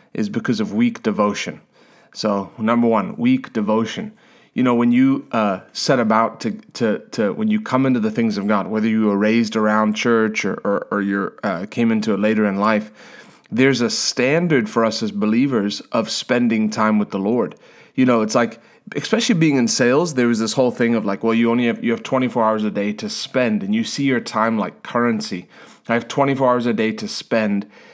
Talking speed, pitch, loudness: 215 wpm, 120 Hz, -19 LUFS